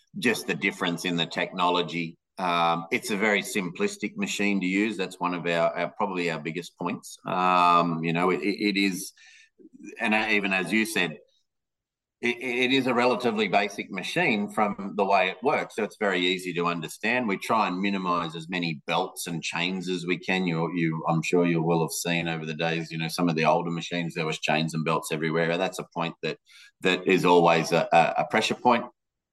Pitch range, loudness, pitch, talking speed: 85-100 Hz, -26 LUFS, 90 Hz, 205 wpm